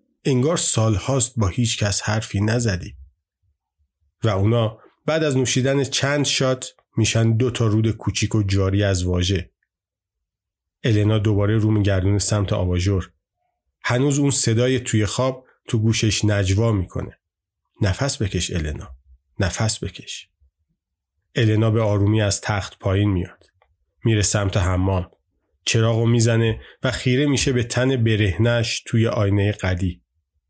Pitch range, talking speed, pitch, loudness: 95-120 Hz, 130 wpm, 105 Hz, -20 LUFS